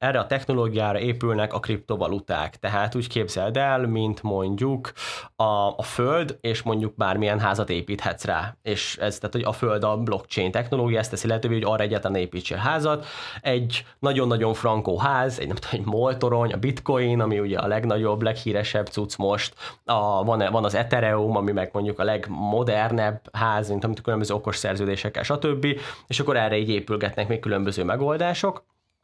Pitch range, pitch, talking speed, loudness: 105-120 Hz, 110 Hz, 165 wpm, -25 LUFS